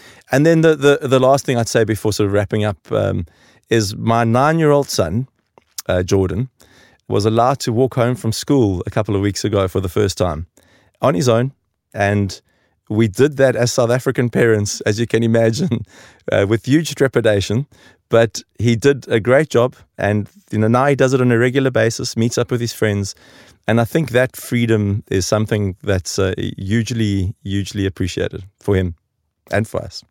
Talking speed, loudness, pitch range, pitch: 195 wpm, -17 LUFS, 100-125 Hz, 115 Hz